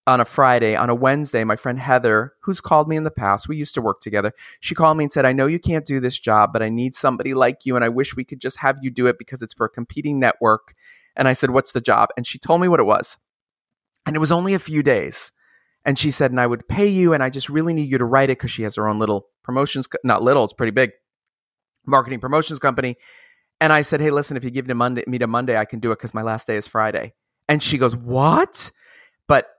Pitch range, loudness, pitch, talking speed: 120-150 Hz, -19 LUFS, 130 Hz, 275 wpm